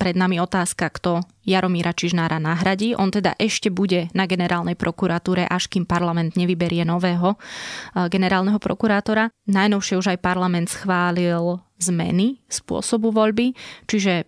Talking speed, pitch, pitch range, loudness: 125 wpm, 185 Hz, 175-195 Hz, -21 LUFS